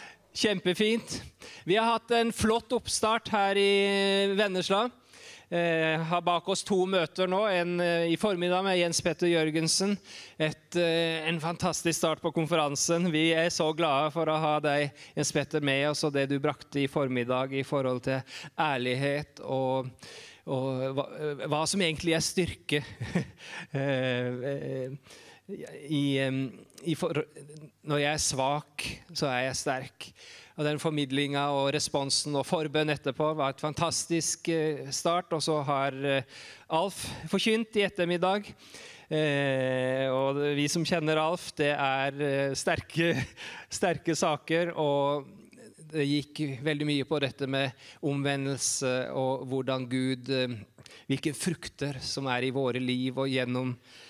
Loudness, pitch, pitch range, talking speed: -29 LUFS, 150 Hz, 135-170 Hz, 140 wpm